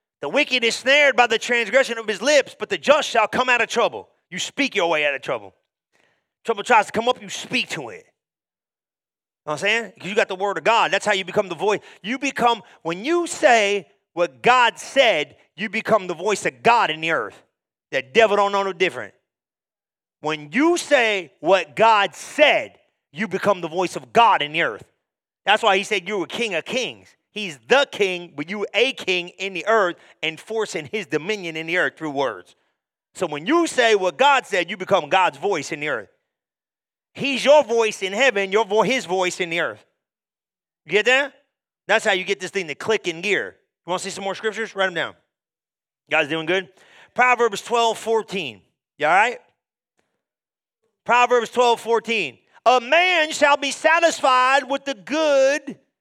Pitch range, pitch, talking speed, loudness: 190-250 Hz, 220 Hz, 200 wpm, -20 LUFS